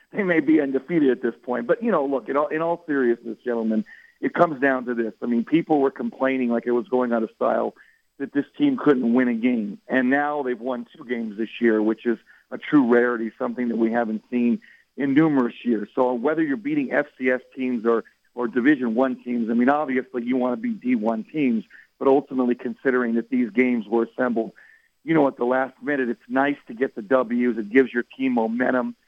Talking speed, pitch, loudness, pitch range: 220 wpm, 125 Hz, -23 LUFS, 120-145 Hz